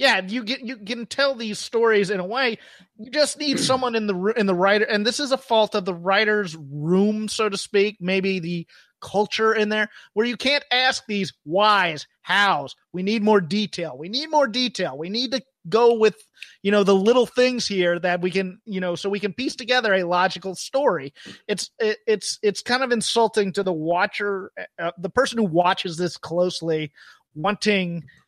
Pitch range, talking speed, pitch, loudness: 185-240 Hz, 195 wpm, 210 Hz, -22 LUFS